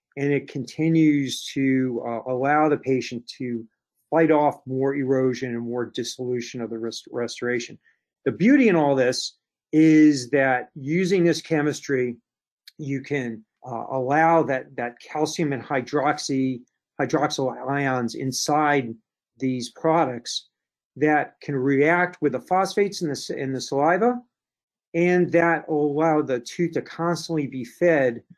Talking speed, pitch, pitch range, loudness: 135 wpm, 140 Hz, 125-155 Hz, -23 LUFS